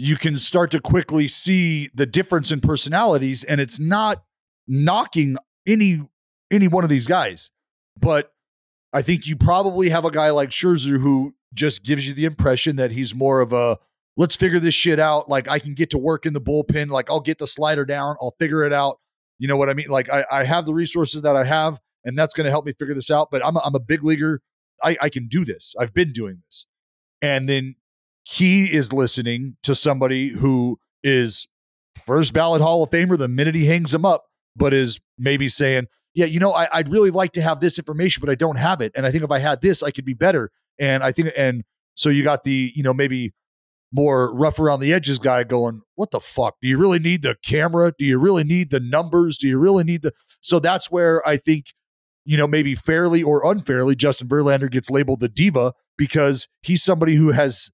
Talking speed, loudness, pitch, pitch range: 225 wpm, -19 LUFS, 145 Hz, 135-165 Hz